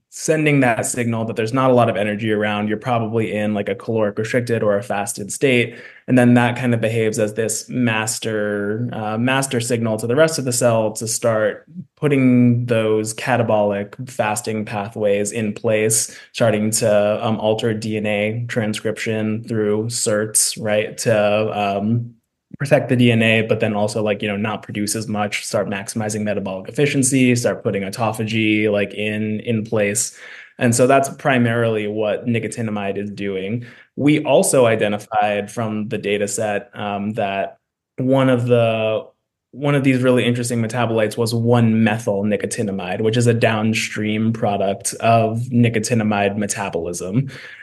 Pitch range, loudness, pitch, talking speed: 105-120 Hz, -19 LUFS, 110 Hz, 155 wpm